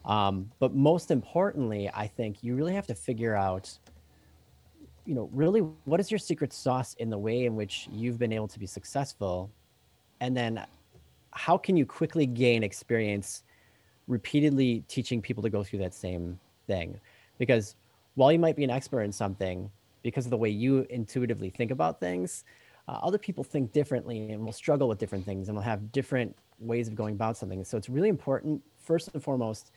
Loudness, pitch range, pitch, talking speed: -30 LUFS, 105-135 Hz, 115 Hz, 185 wpm